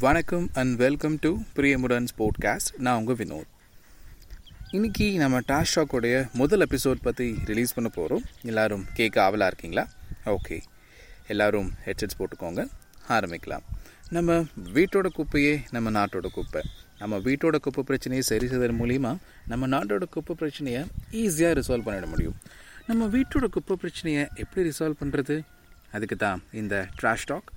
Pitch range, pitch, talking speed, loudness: 110-155 Hz, 130 Hz, 130 wpm, -27 LUFS